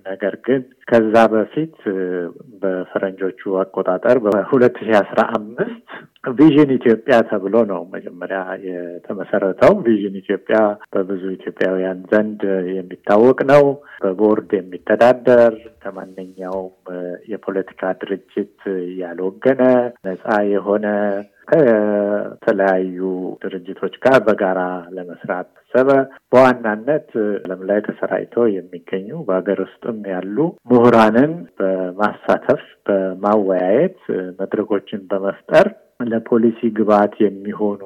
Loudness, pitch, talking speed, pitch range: -17 LUFS, 100 Hz, 80 wpm, 95-115 Hz